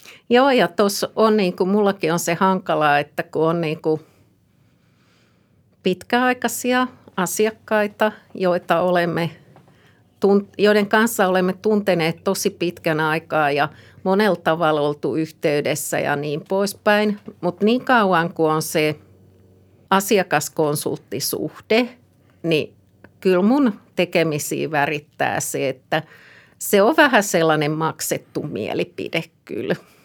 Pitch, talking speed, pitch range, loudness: 175 Hz, 110 wpm, 155-210 Hz, -20 LUFS